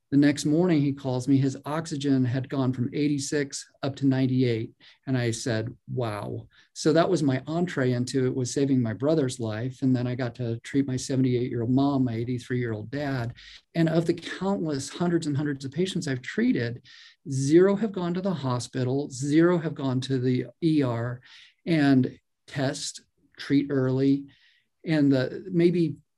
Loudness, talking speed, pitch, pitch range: -26 LUFS, 165 wpm, 135 Hz, 125-150 Hz